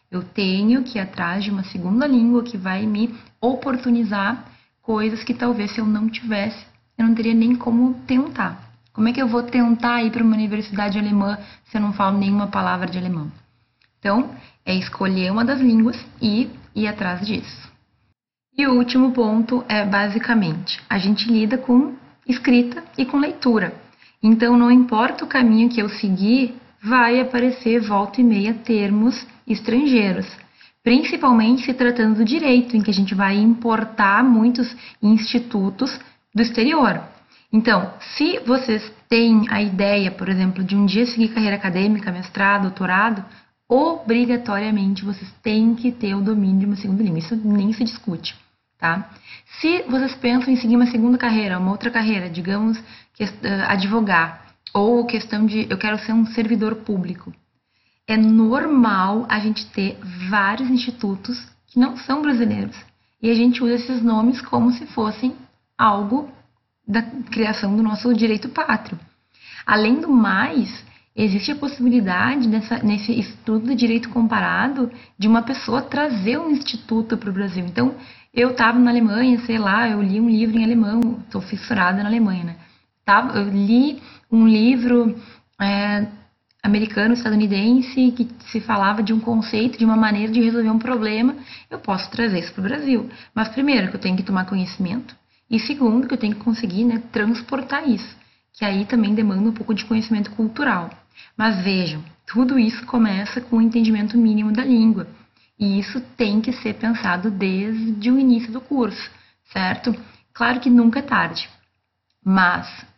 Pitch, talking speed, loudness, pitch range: 225 Hz, 160 wpm, -19 LUFS, 205-245 Hz